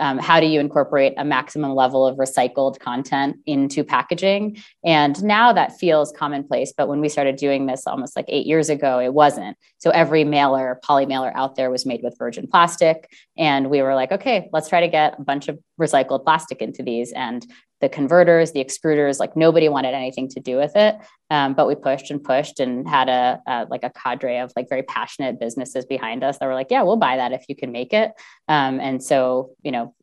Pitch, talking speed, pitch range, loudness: 140 Hz, 220 wpm, 130-160 Hz, -19 LUFS